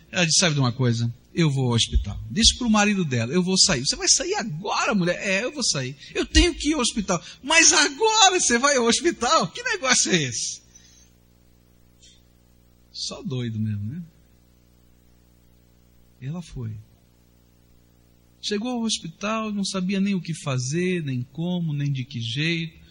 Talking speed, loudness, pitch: 170 wpm, -21 LUFS, 140 Hz